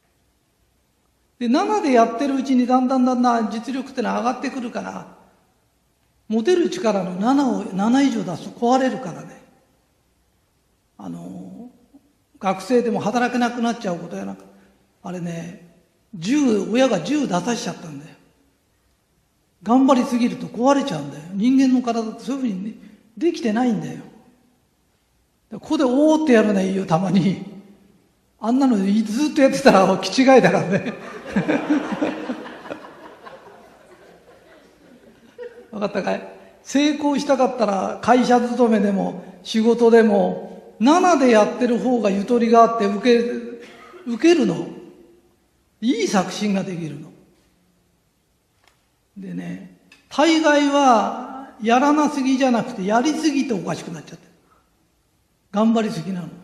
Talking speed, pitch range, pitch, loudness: 265 characters per minute, 195-260 Hz, 235 Hz, -19 LUFS